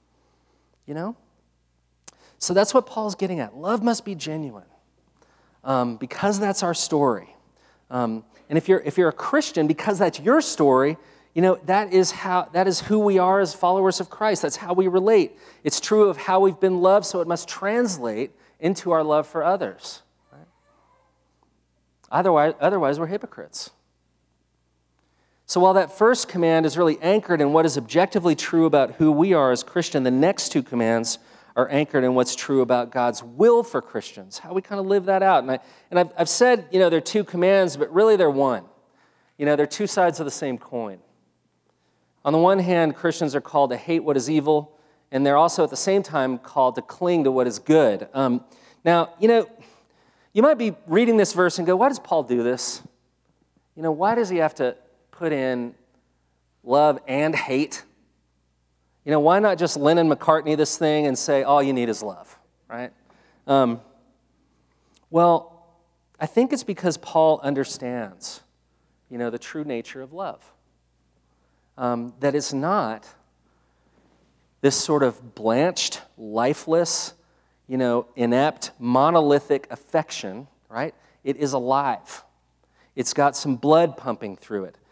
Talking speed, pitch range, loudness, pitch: 175 wpm, 120-180 Hz, -21 LUFS, 150 Hz